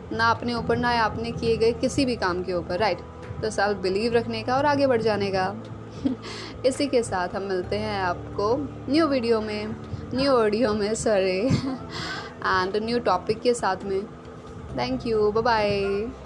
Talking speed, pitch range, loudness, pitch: 180 wpm, 200-240 Hz, -25 LUFS, 220 Hz